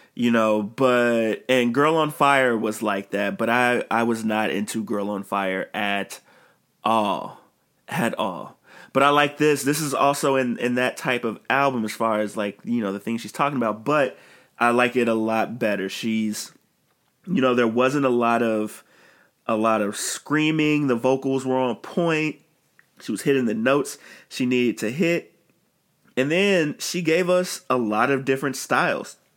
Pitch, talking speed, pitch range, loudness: 120 Hz, 185 wpm, 110-140 Hz, -22 LUFS